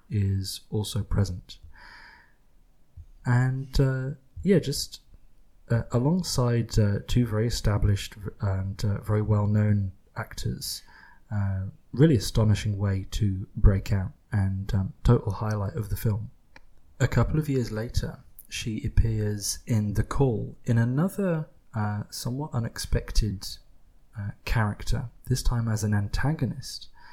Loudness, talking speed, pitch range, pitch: -27 LUFS, 120 wpm, 100-125 Hz, 110 Hz